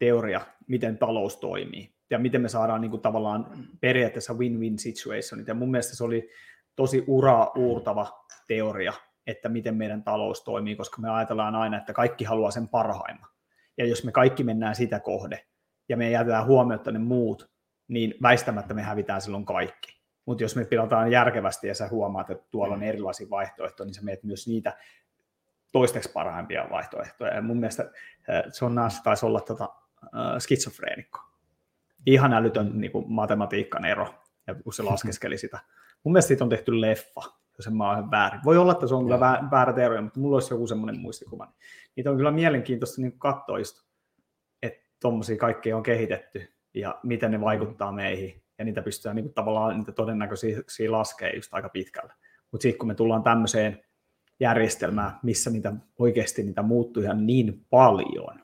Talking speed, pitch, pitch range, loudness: 170 wpm, 115 Hz, 105-120 Hz, -26 LUFS